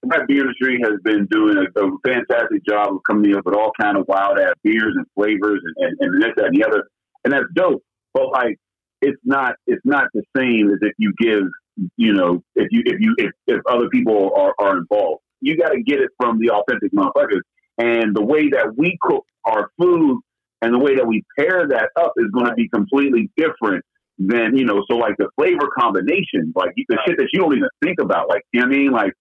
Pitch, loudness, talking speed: 150 Hz, -18 LUFS, 230 wpm